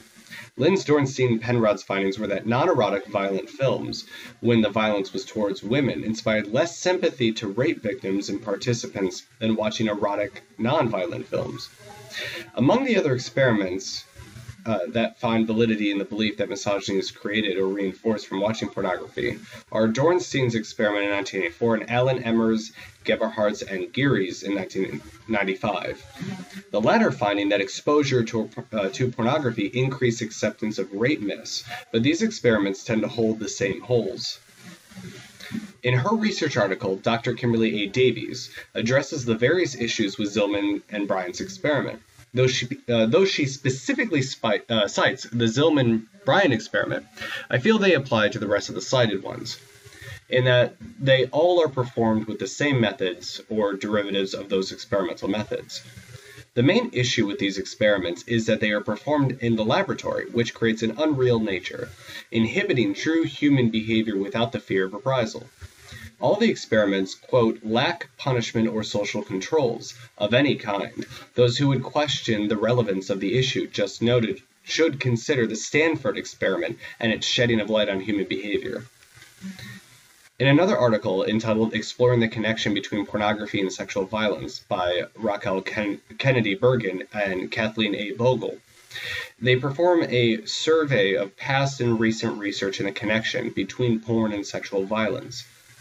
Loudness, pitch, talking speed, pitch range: -24 LUFS, 115 Hz, 155 wpm, 105-125 Hz